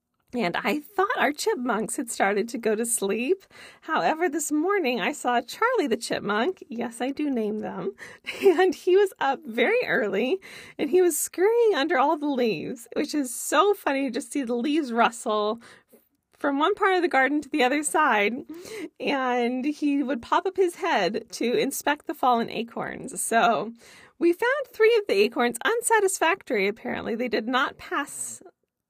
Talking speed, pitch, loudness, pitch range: 170 wpm, 290 Hz, -25 LUFS, 245-370 Hz